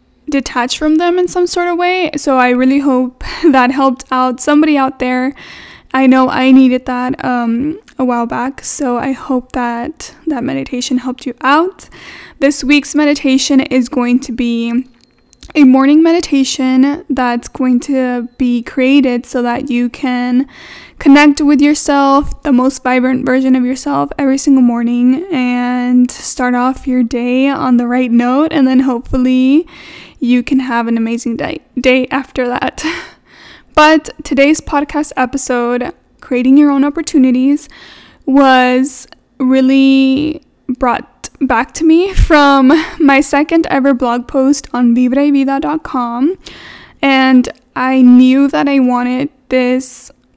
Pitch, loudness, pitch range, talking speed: 265 Hz, -12 LUFS, 250-290 Hz, 140 wpm